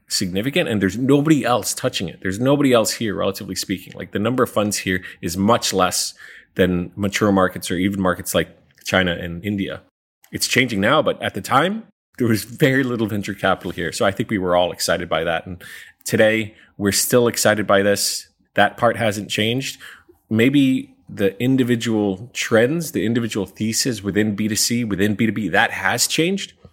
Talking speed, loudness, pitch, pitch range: 180 wpm, -19 LUFS, 105 Hz, 95-120 Hz